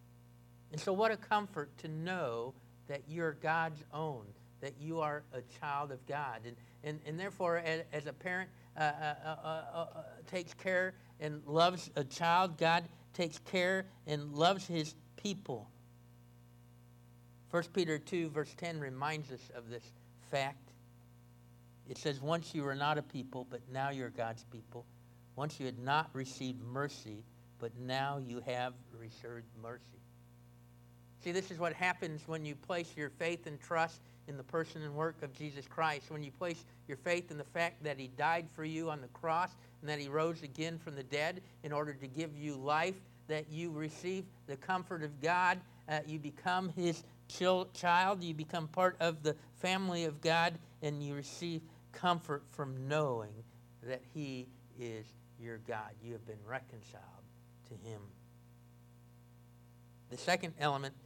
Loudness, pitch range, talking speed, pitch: -38 LUFS, 120-165 Hz, 165 wpm, 145 Hz